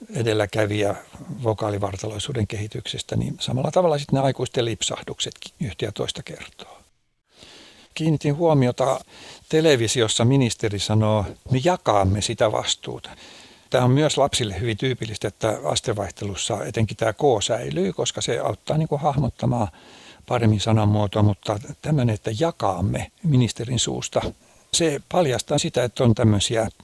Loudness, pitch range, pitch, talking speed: -22 LUFS, 110-145 Hz, 120 Hz, 125 wpm